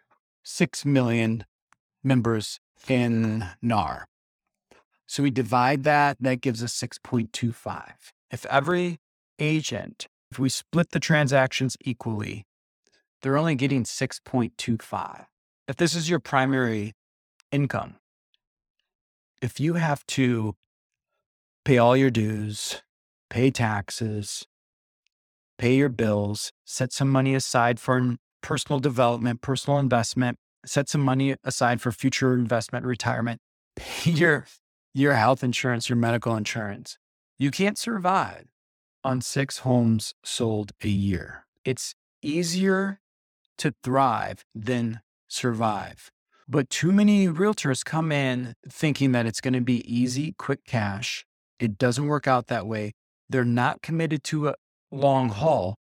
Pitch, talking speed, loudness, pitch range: 125 Hz, 120 wpm, -25 LUFS, 115-140 Hz